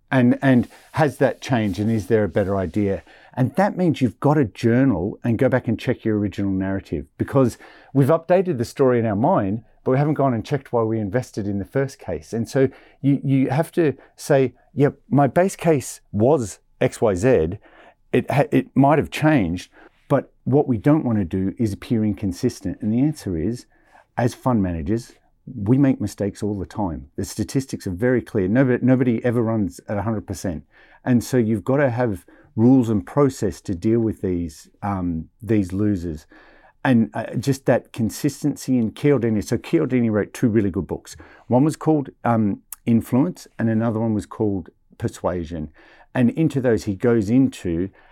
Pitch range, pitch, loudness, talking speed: 100-130 Hz, 115 Hz, -21 LUFS, 185 wpm